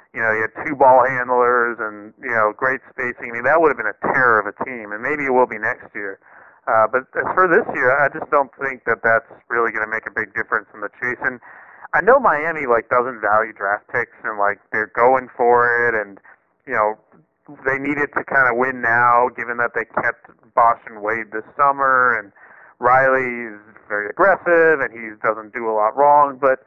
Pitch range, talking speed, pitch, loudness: 110-130 Hz, 225 wpm, 120 Hz, -18 LUFS